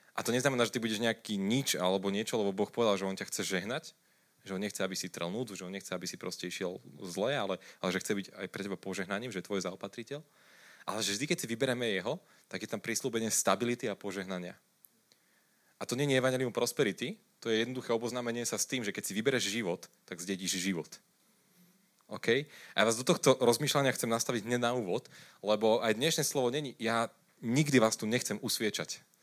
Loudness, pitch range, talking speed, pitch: -33 LUFS, 100-130 Hz, 215 wpm, 115 Hz